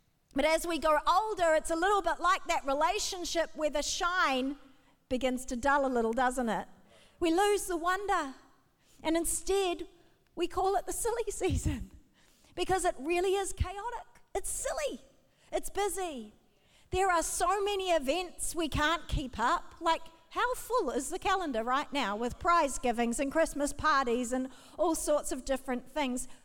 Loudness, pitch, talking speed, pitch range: -31 LUFS, 330 Hz, 165 wpm, 275-365 Hz